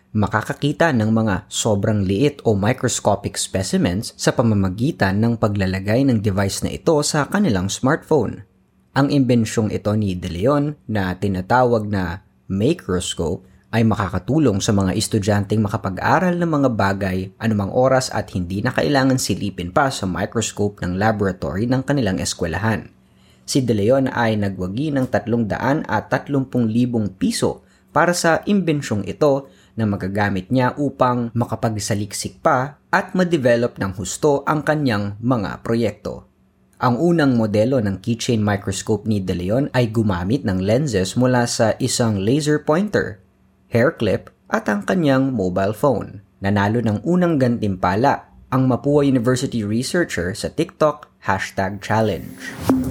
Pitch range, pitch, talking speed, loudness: 100-135 Hz, 110 Hz, 135 wpm, -19 LUFS